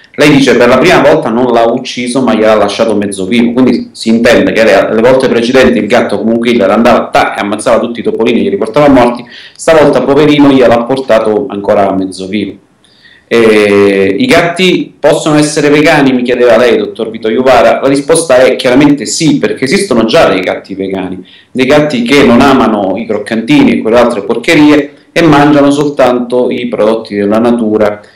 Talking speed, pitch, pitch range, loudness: 180 wpm, 125 Hz, 110-145 Hz, -7 LUFS